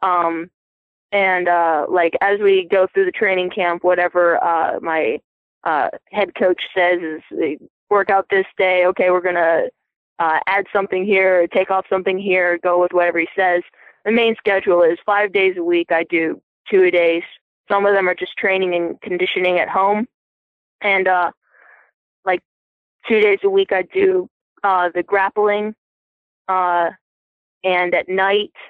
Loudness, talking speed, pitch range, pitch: -17 LUFS, 165 wpm, 175-200 Hz, 185 Hz